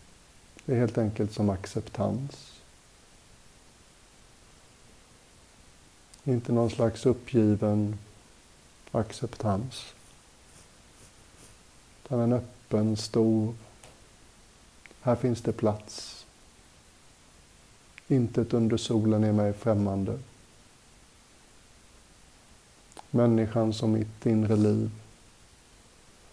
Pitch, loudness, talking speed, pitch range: 110 Hz, -28 LUFS, 70 wpm, 105-120 Hz